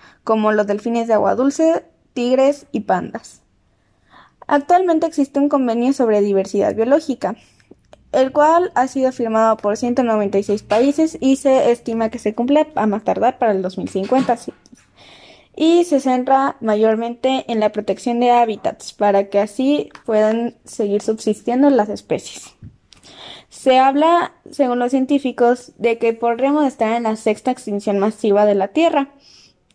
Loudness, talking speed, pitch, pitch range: -17 LUFS, 140 wpm, 240 Hz, 215-275 Hz